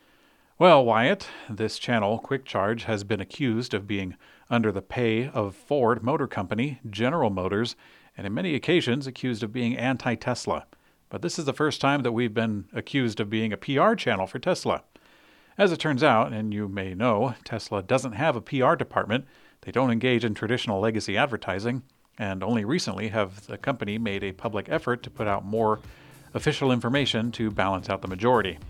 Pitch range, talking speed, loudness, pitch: 105-130 Hz, 185 wpm, -26 LUFS, 115 Hz